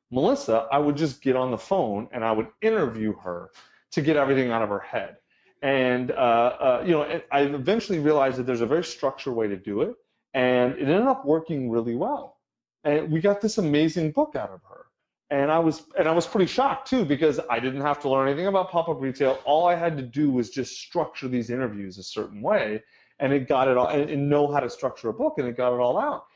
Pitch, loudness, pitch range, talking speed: 140 Hz, -24 LUFS, 125-160 Hz, 235 wpm